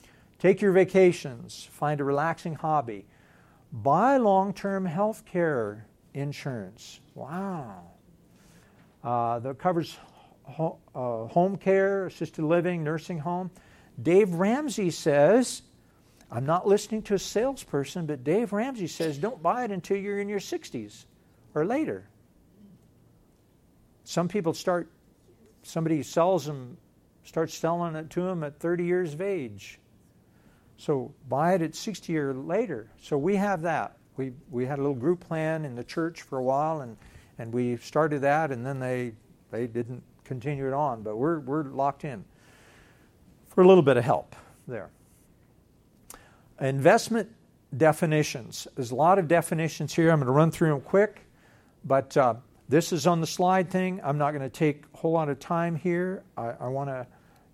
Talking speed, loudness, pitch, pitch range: 155 wpm, -27 LUFS, 160 Hz, 135-180 Hz